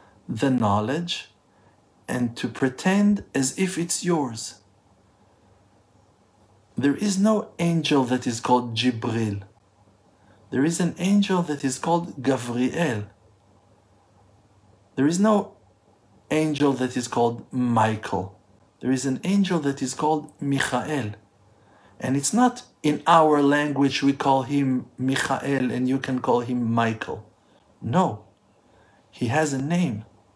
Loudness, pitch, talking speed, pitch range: -23 LUFS, 125 Hz, 125 wpm, 105-150 Hz